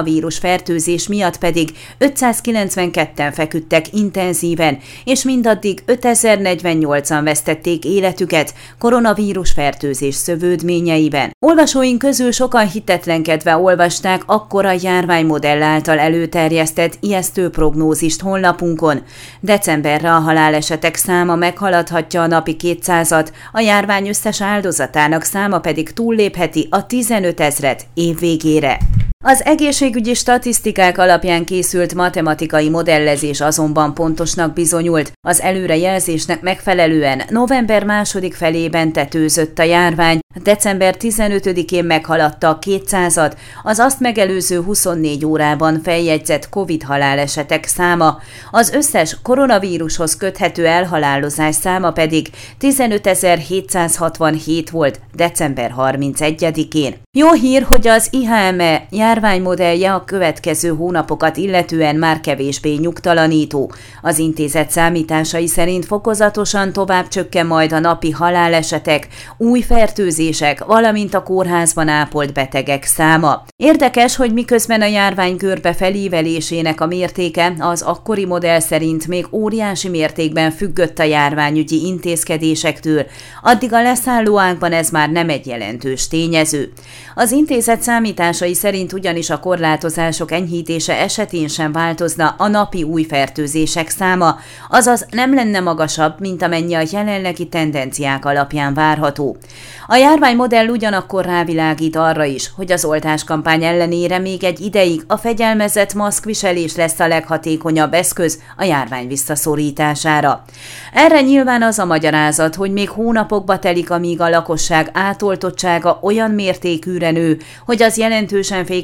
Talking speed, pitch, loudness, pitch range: 110 wpm, 170 Hz, -14 LUFS, 155-195 Hz